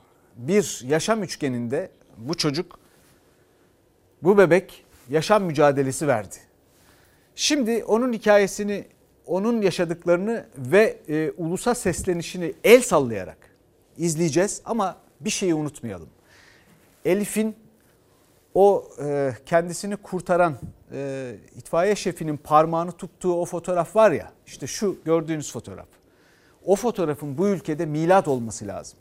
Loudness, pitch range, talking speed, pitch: -23 LUFS, 140-195 Hz, 105 wpm, 170 Hz